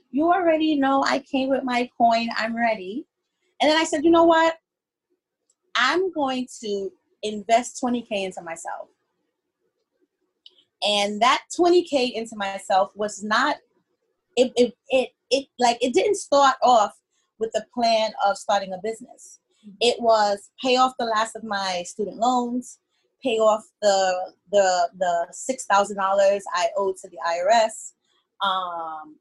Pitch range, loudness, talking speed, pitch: 200-285 Hz, -22 LUFS, 140 wpm, 230 Hz